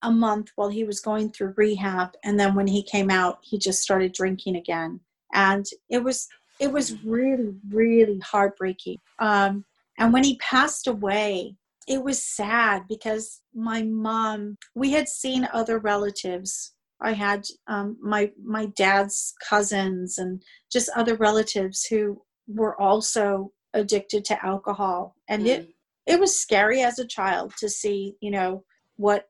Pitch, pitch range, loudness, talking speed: 210 Hz, 195-225 Hz, -24 LUFS, 150 wpm